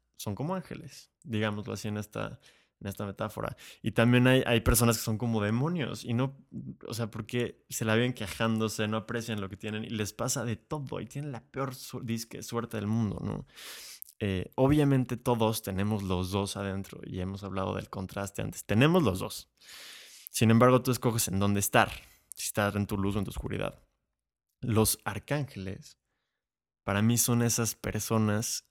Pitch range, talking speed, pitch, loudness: 100-125 Hz, 180 wpm, 110 Hz, -30 LUFS